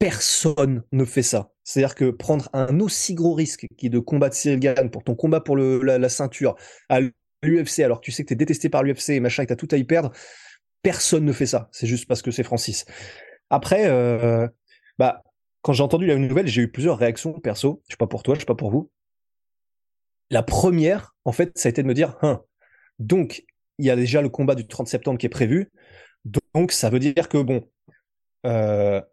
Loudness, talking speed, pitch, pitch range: -22 LUFS, 225 wpm, 135 Hz, 120-155 Hz